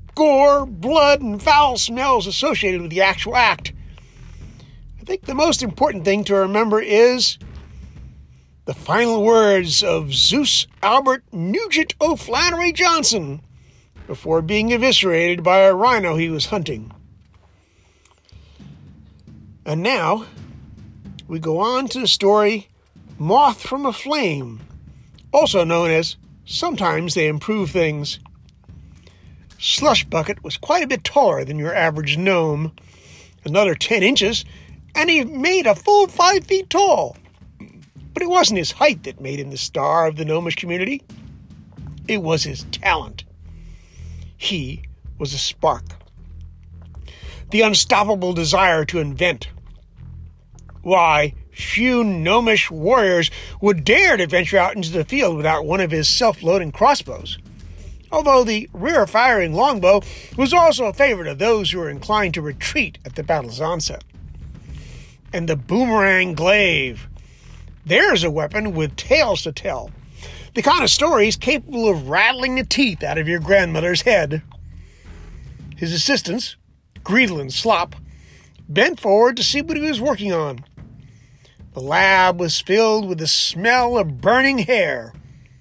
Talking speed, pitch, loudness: 135 wpm, 180 Hz, -17 LUFS